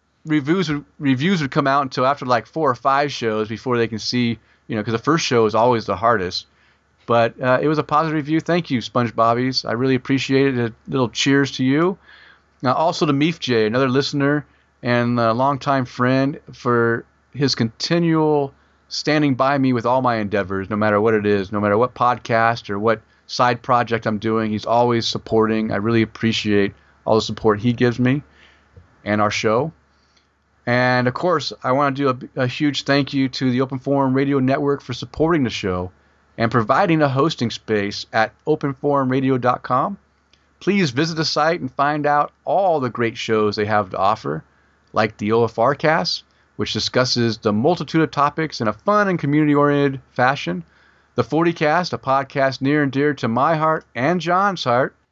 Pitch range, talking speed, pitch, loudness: 110-145 Hz, 185 wpm, 125 Hz, -19 LUFS